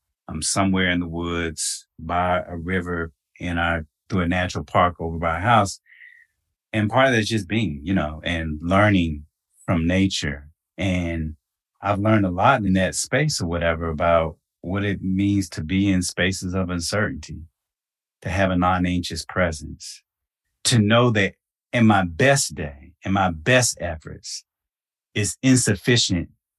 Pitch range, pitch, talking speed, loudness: 85-100 Hz, 90 Hz, 155 wpm, -21 LUFS